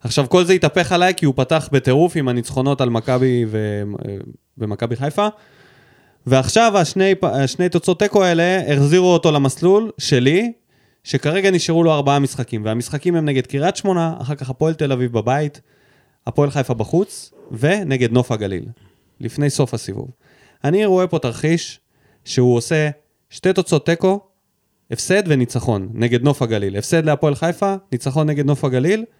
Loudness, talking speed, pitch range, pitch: -17 LUFS, 145 wpm, 125-175 Hz, 145 Hz